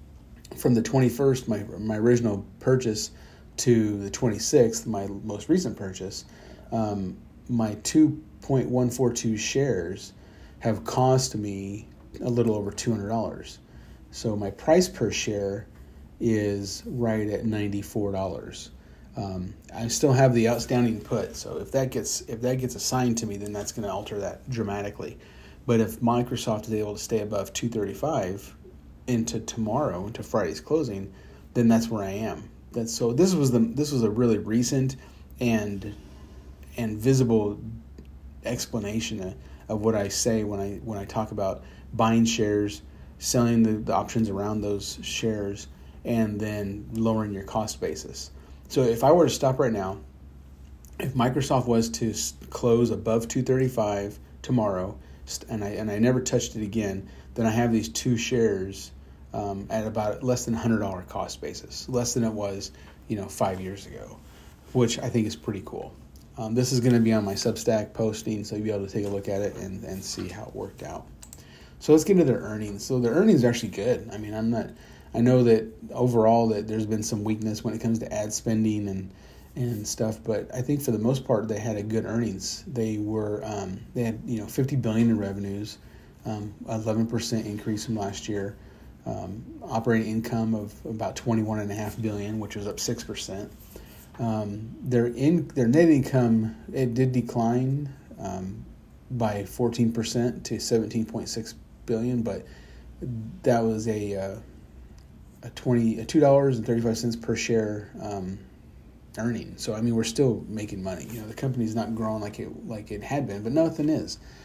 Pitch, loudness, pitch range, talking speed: 110 Hz, -26 LUFS, 100-120 Hz, 175 wpm